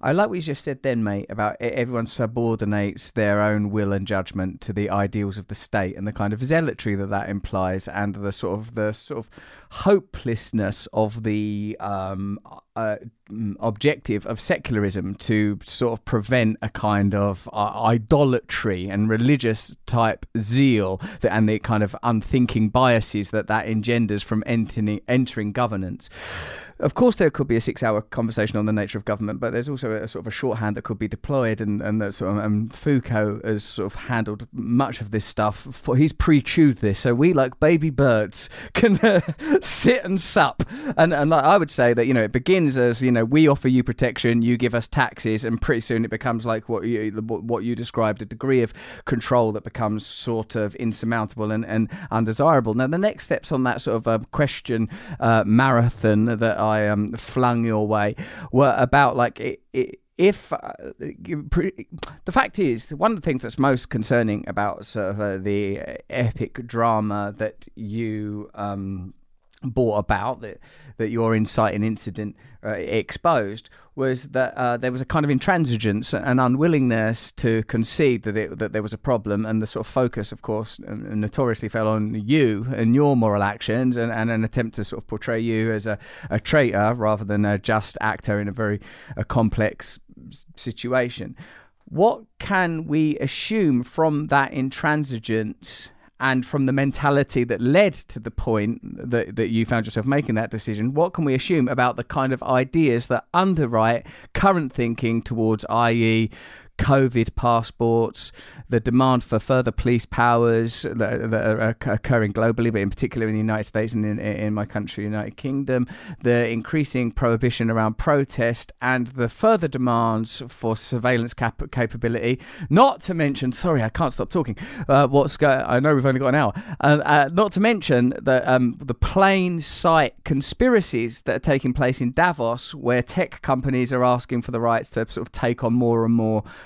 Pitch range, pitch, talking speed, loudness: 110-130 Hz, 115 Hz, 185 wpm, -22 LUFS